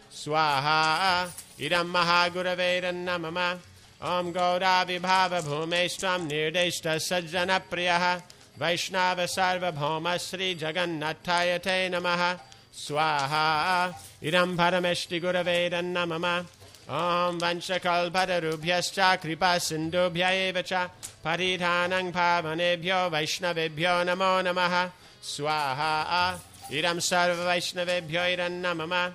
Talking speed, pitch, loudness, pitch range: 60 wpm, 175 Hz, -26 LUFS, 165-180 Hz